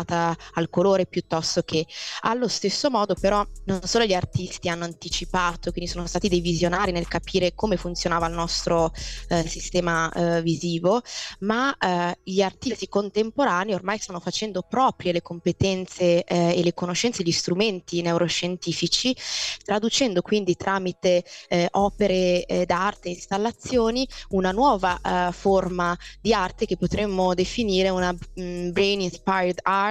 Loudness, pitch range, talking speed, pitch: -24 LUFS, 175-200 Hz, 140 wpm, 180 Hz